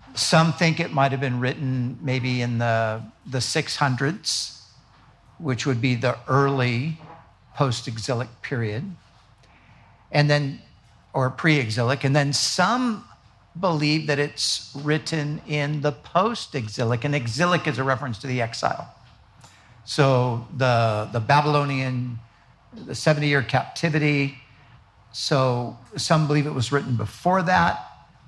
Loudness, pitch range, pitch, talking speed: -23 LUFS, 120-150 Hz, 130 Hz, 120 wpm